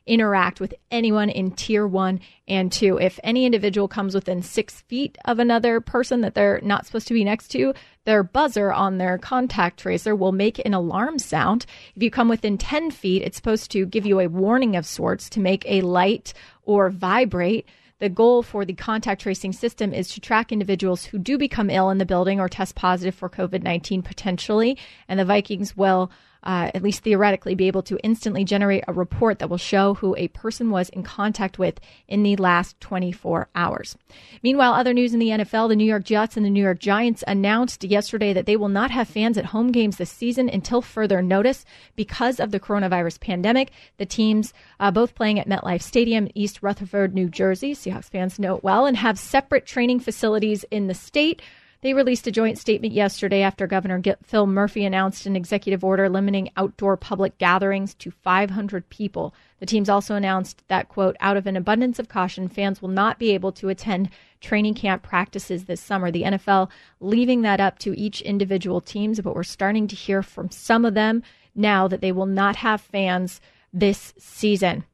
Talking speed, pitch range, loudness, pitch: 200 wpm, 190-220 Hz, -22 LUFS, 200 Hz